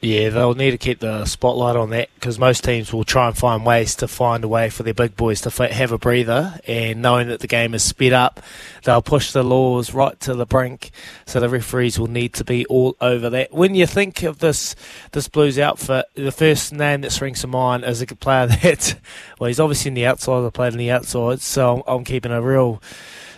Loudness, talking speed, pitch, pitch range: -18 LUFS, 235 wpm, 125 Hz, 120-130 Hz